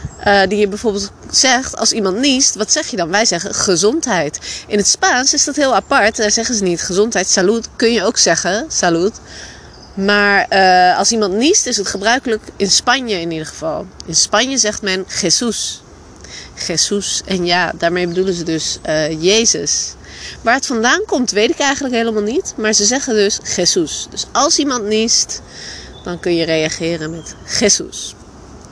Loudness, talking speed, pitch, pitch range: -14 LUFS, 175 wpm, 210 Hz, 180-235 Hz